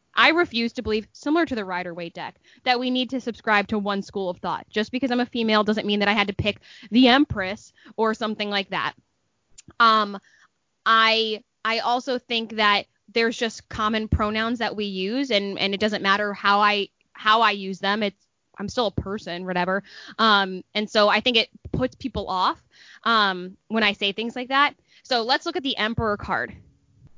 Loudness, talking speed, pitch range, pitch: -22 LUFS, 200 wpm, 200-235 Hz, 215 Hz